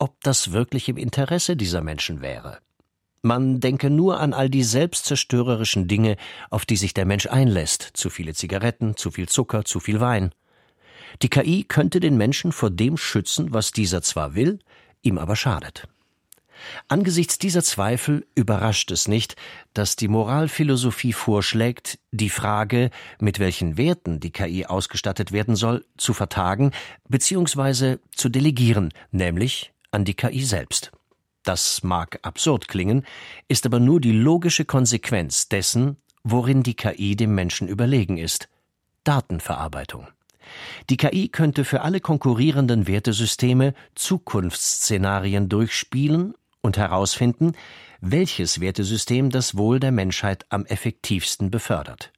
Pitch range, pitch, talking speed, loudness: 100-135 Hz, 115 Hz, 130 wpm, -22 LUFS